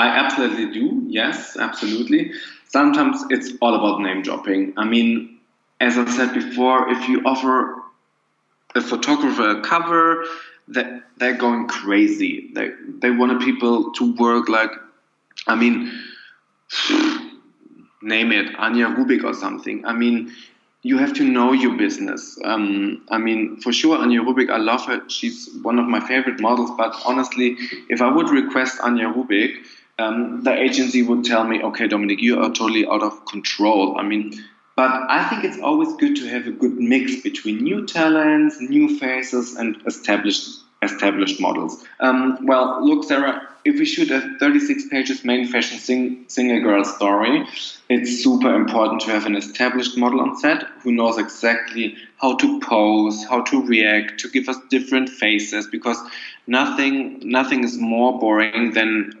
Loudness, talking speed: -19 LUFS, 160 wpm